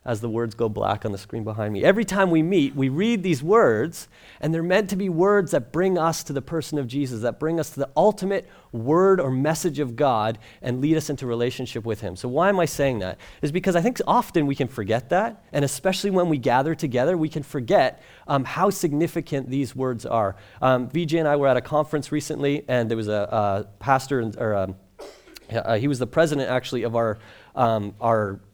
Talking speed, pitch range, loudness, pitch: 225 wpm, 115-165 Hz, -23 LUFS, 140 Hz